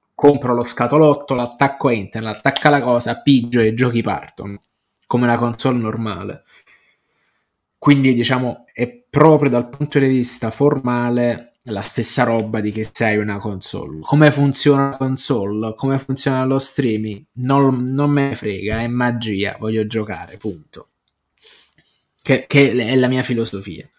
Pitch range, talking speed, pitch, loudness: 110-135 Hz, 145 wpm, 120 Hz, -17 LUFS